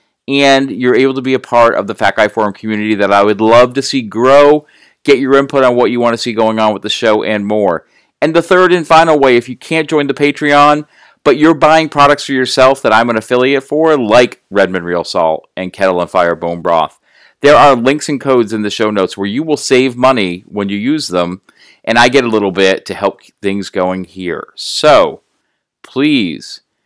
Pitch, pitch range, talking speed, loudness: 125 Hz, 105-145 Hz, 225 wpm, -11 LUFS